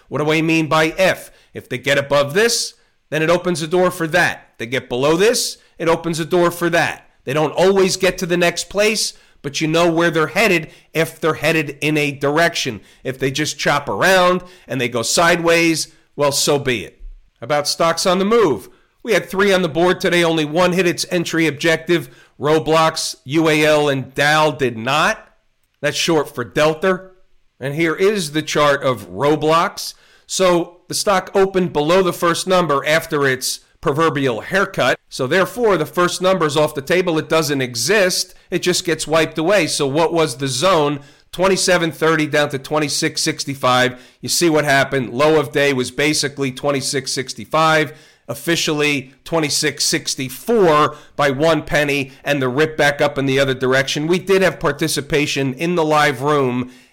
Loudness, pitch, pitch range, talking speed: -17 LUFS, 155 Hz, 140-175 Hz, 175 wpm